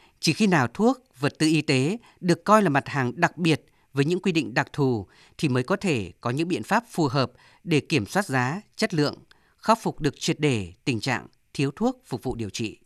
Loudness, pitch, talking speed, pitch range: -25 LUFS, 150 Hz, 235 wpm, 130-180 Hz